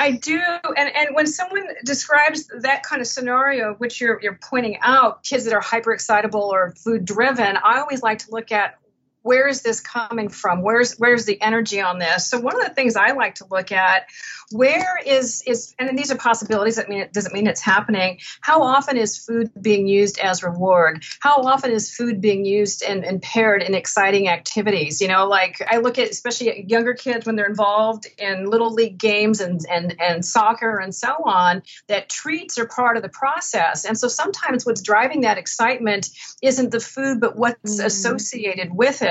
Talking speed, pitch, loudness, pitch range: 205 wpm, 225 Hz, -19 LUFS, 200-255 Hz